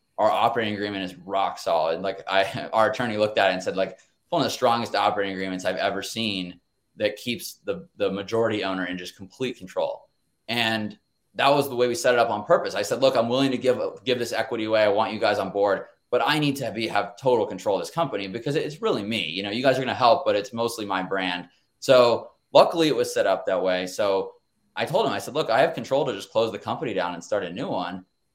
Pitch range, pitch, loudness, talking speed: 95-125 Hz, 110 Hz, -24 LUFS, 255 wpm